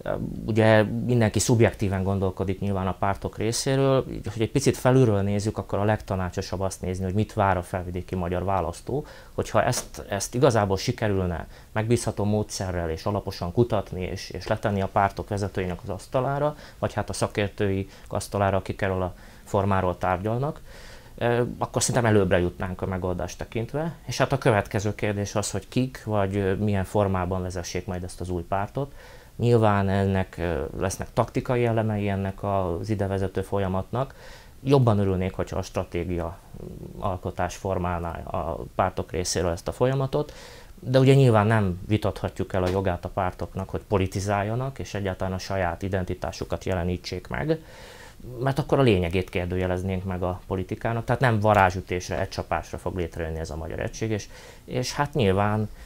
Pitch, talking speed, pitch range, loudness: 100 Hz, 155 wpm, 95-115 Hz, -26 LUFS